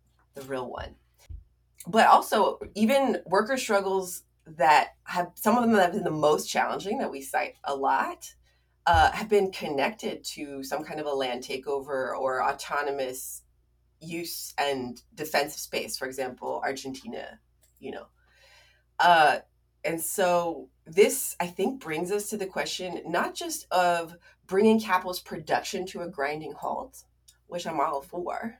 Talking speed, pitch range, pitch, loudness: 150 wpm, 130-190 Hz, 165 Hz, -27 LUFS